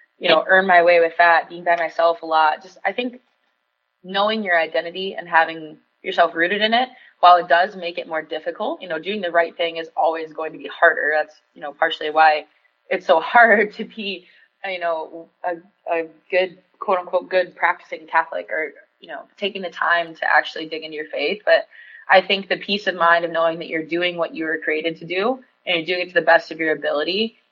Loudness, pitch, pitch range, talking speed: -19 LUFS, 170 Hz, 160-185 Hz, 220 wpm